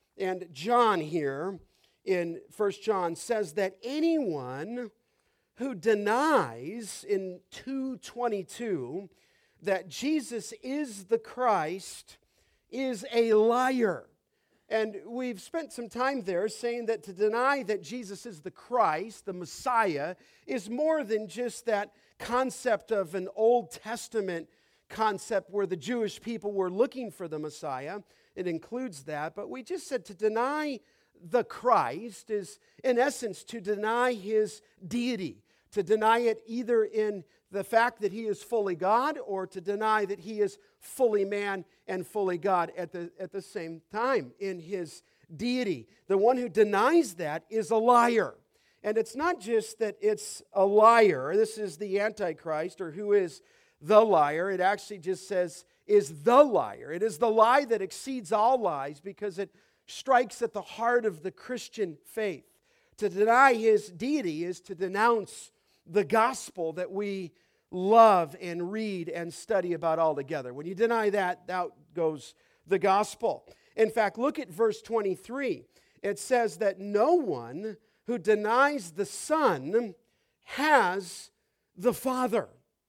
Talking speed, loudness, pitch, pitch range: 145 wpm, -28 LUFS, 215 Hz, 190-240 Hz